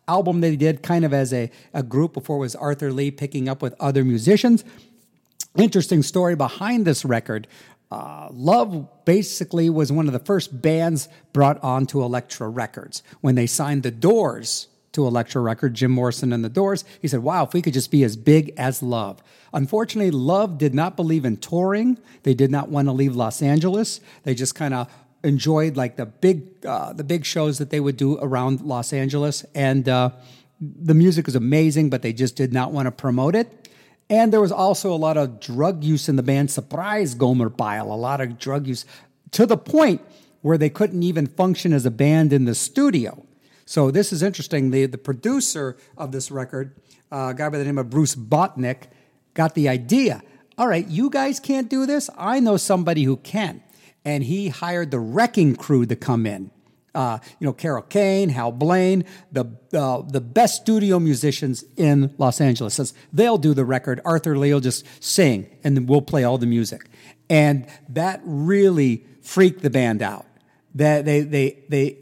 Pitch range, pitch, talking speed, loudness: 130-175 Hz, 145 Hz, 195 wpm, -21 LUFS